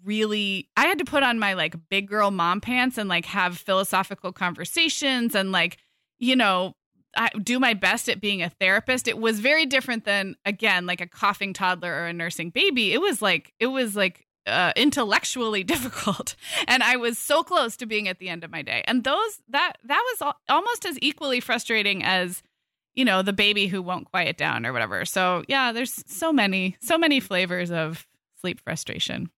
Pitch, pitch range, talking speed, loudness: 210 Hz, 185-255 Hz, 200 wpm, -23 LUFS